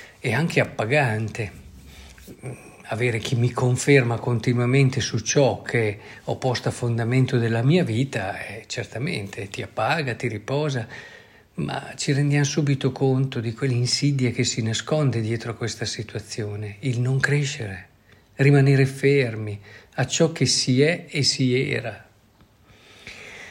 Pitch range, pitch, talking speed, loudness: 110-135 Hz, 120 Hz, 130 wpm, -23 LUFS